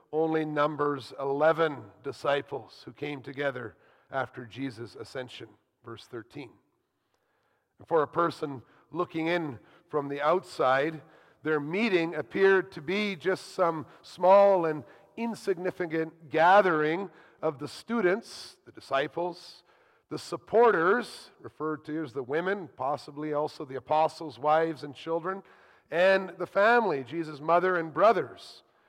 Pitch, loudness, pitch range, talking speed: 160 Hz, -28 LUFS, 150-180 Hz, 120 wpm